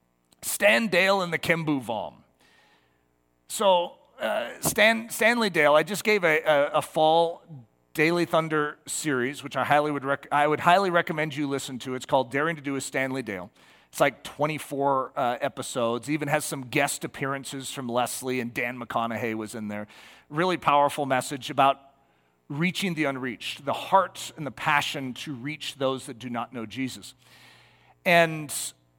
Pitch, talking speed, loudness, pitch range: 145 Hz, 165 wpm, -25 LUFS, 125-155 Hz